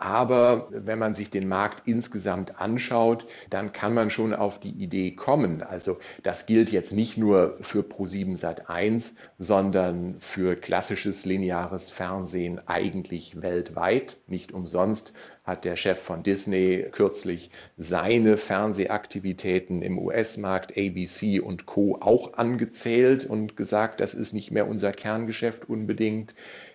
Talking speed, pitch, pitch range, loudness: 130 wpm, 100 Hz, 95-110 Hz, -26 LUFS